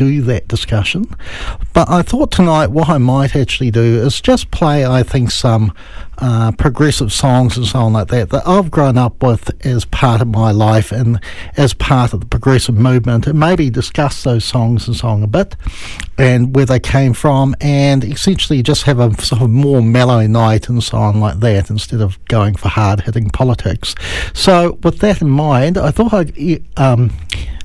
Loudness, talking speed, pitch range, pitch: -13 LUFS, 190 wpm, 110-140 Hz, 125 Hz